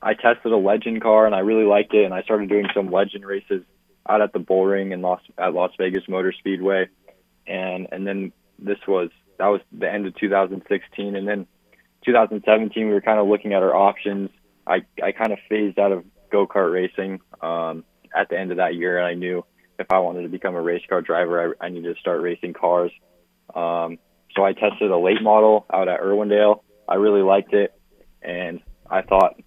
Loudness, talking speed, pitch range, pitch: -21 LUFS, 210 wpm, 90-105 Hz, 95 Hz